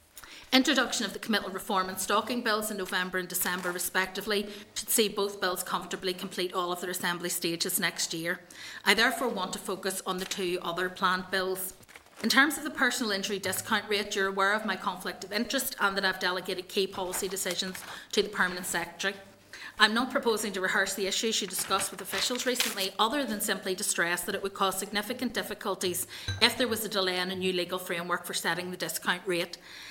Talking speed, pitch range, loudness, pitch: 210 wpm, 185-210 Hz, -29 LUFS, 195 Hz